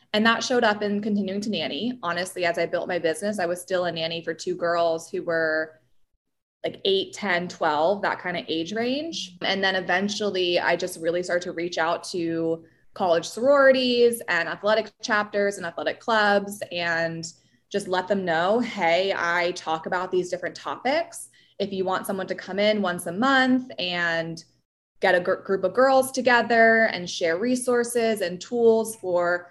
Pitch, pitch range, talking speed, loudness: 185 Hz, 170-220 Hz, 175 wpm, -24 LUFS